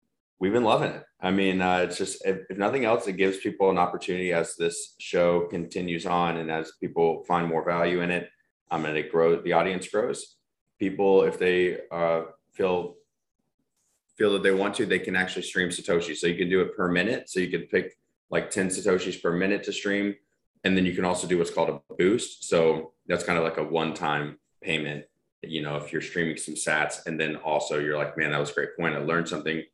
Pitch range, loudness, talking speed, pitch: 80-95 Hz, -26 LUFS, 225 wpm, 85 Hz